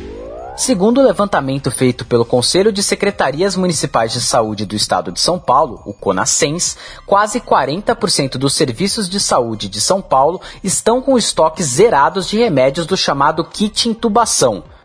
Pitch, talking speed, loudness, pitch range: 185 Hz, 150 wpm, -14 LUFS, 135-210 Hz